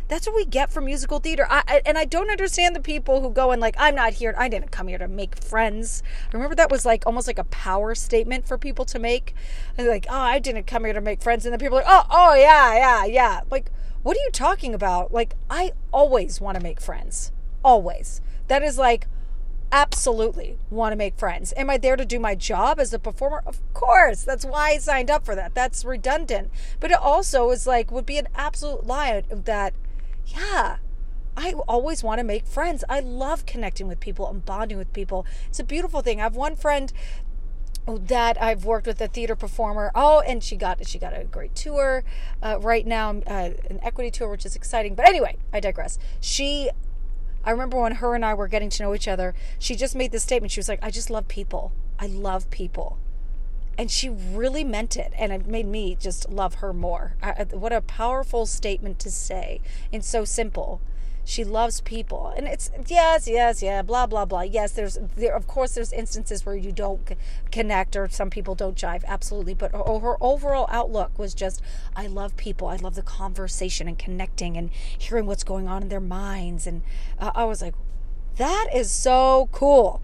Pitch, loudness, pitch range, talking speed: 230 Hz, -23 LUFS, 200-270 Hz, 210 wpm